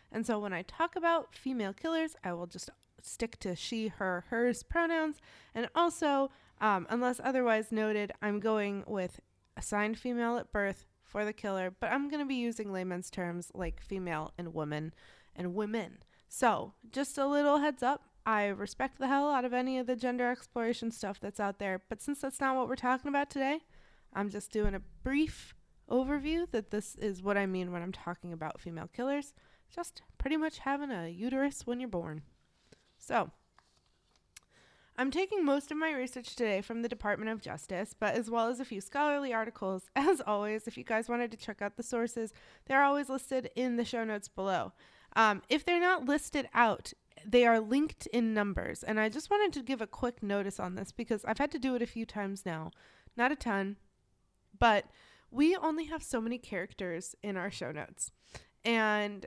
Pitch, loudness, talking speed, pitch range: 230 Hz, -34 LUFS, 195 wpm, 200-270 Hz